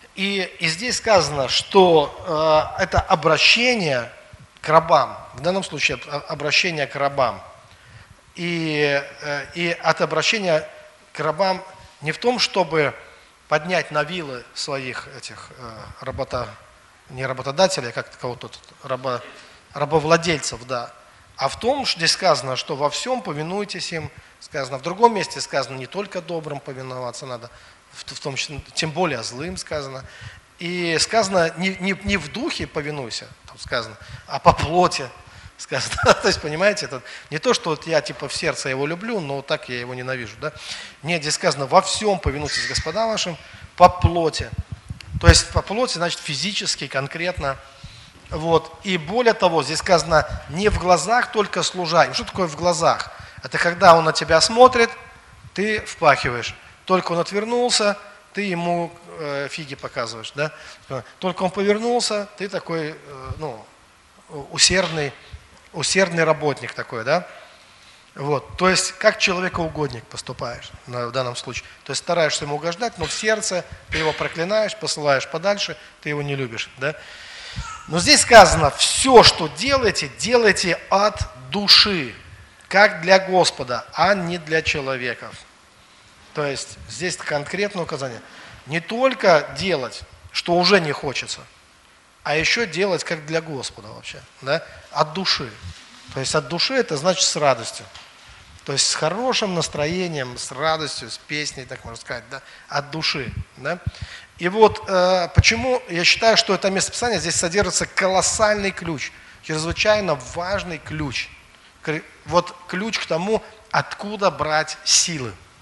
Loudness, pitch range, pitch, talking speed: -20 LUFS, 140-190 Hz, 160 Hz, 145 wpm